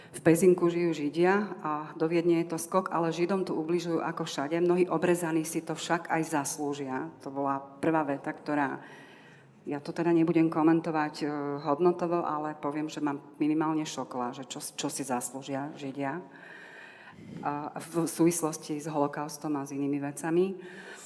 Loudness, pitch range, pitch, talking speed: -30 LUFS, 145-170 Hz, 155 Hz, 155 wpm